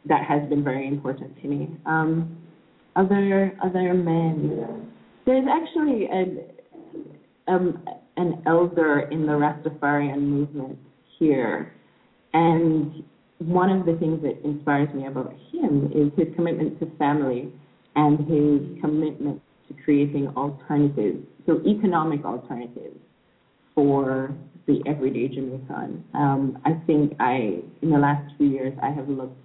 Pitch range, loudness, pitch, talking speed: 145-170 Hz, -23 LUFS, 150 Hz, 125 wpm